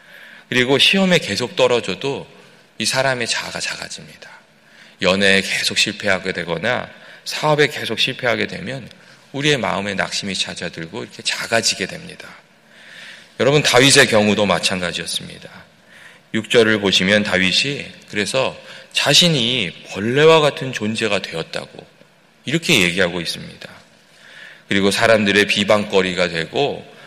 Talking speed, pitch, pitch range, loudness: 305 characters per minute, 110 Hz, 100-140 Hz, -17 LUFS